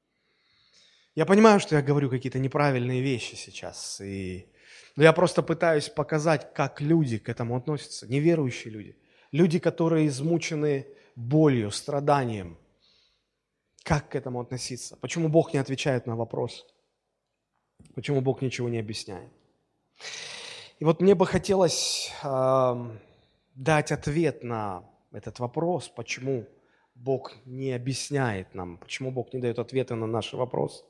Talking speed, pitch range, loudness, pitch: 130 wpm, 120-160 Hz, -26 LUFS, 135 Hz